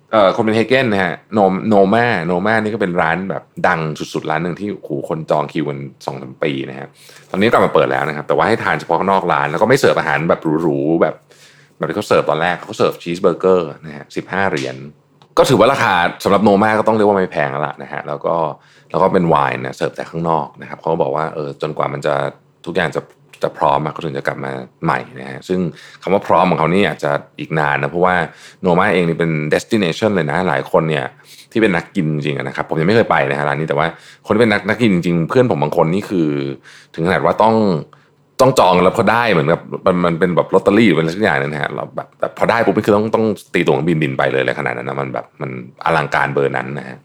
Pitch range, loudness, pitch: 70-95 Hz, -16 LUFS, 80 Hz